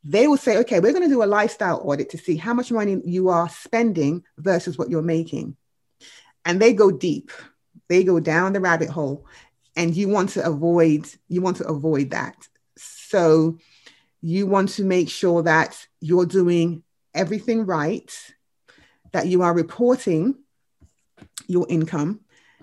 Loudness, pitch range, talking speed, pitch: -21 LUFS, 160-195 Hz, 160 wpm, 175 Hz